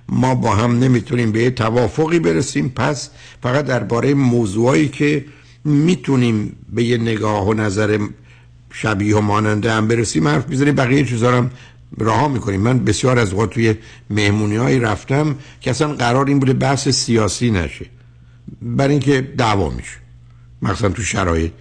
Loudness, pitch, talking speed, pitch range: -17 LUFS, 120 Hz, 145 wpm, 105-135 Hz